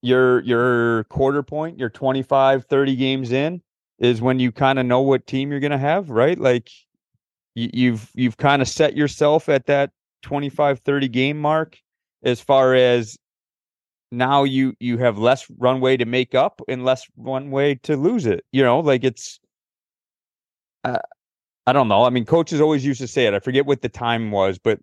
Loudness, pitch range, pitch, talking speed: -19 LUFS, 125-140 Hz, 130 Hz, 190 wpm